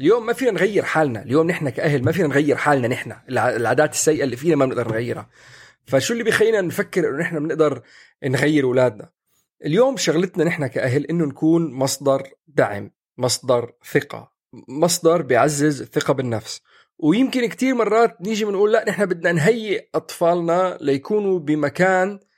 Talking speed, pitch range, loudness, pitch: 145 wpm, 140-205 Hz, -20 LUFS, 165 Hz